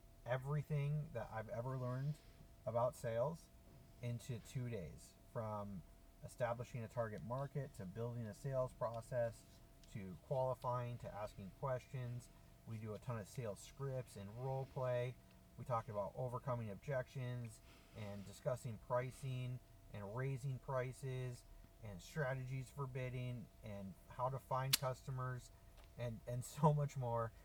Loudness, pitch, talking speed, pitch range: -45 LUFS, 125 Hz, 130 wpm, 110-130 Hz